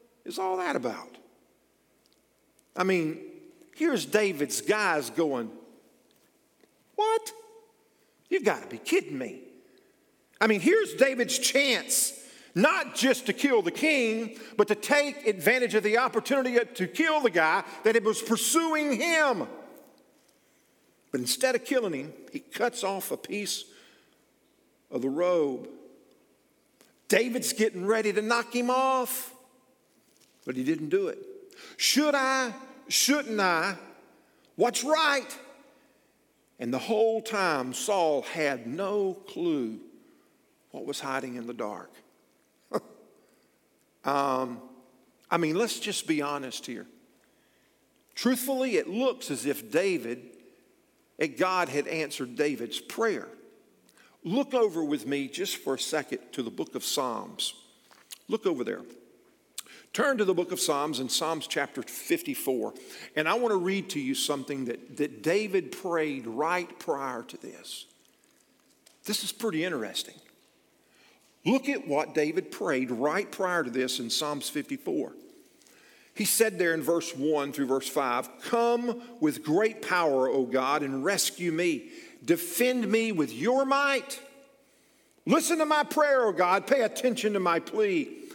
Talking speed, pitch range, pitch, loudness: 135 wpm, 175-285 Hz, 235 Hz, -28 LUFS